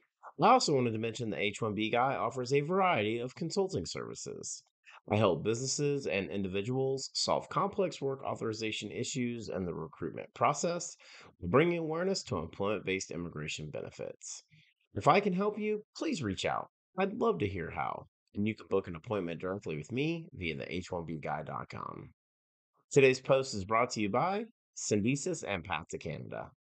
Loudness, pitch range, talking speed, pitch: -33 LUFS, 95-160 Hz, 170 wpm, 120 Hz